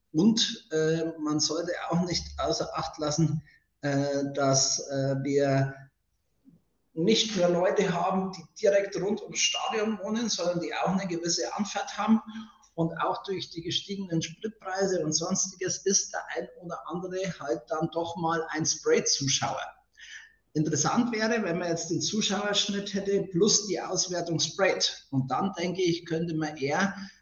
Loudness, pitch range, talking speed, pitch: -28 LUFS, 155-195 Hz, 150 wpm, 170 Hz